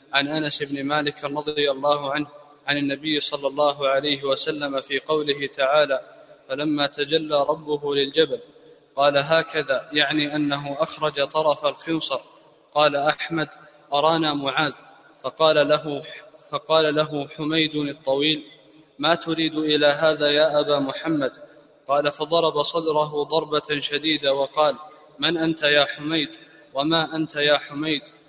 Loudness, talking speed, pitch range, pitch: -22 LUFS, 125 wpm, 145-155 Hz, 150 Hz